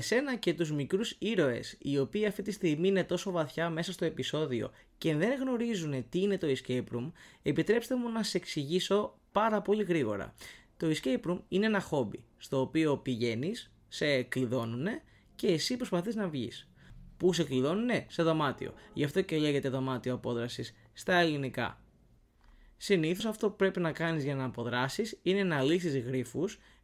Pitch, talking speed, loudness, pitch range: 165 Hz, 165 wpm, -32 LUFS, 130-195 Hz